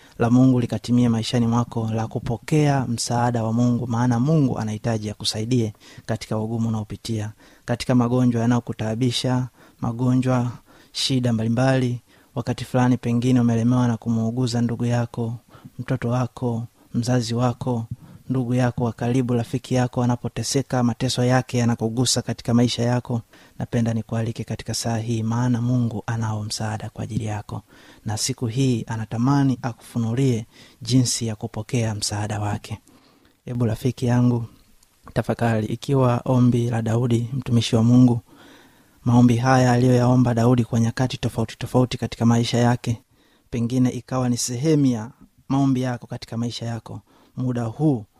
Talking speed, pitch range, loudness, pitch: 125 wpm, 115-125 Hz, -22 LUFS, 120 Hz